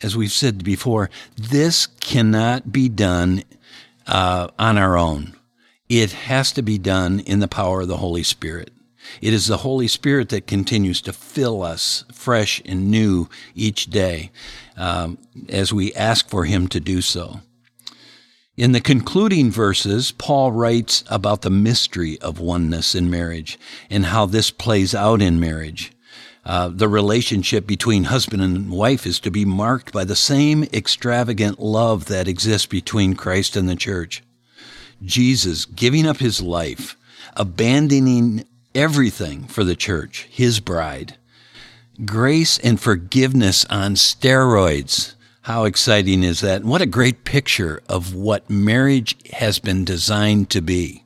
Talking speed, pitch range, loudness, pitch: 145 wpm, 95-120 Hz, -18 LUFS, 105 Hz